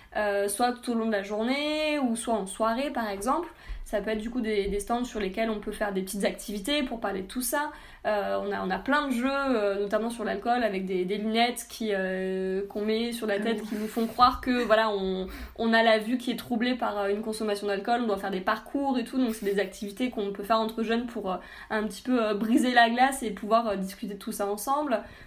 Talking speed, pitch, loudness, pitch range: 260 wpm, 220 Hz, -28 LUFS, 205-240 Hz